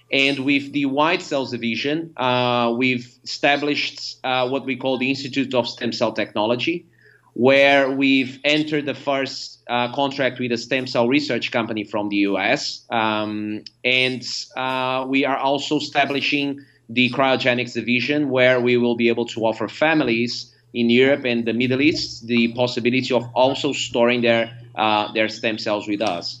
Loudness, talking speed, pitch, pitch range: -20 LUFS, 160 wpm, 125 Hz, 120-135 Hz